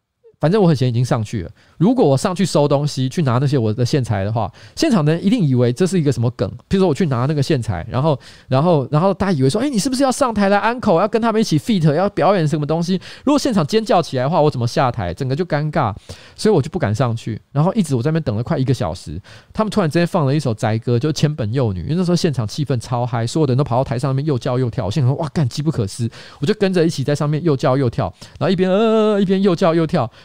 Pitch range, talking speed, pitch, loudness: 125-185 Hz, 430 characters per minute, 150 Hz, -18 LUFS